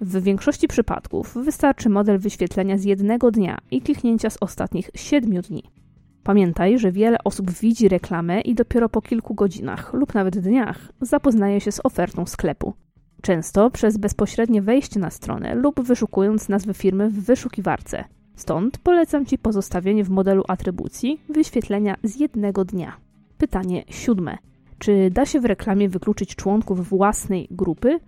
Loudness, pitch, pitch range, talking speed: -21 LUFS, 205 Hz, 195-240 Hz, 145 wpm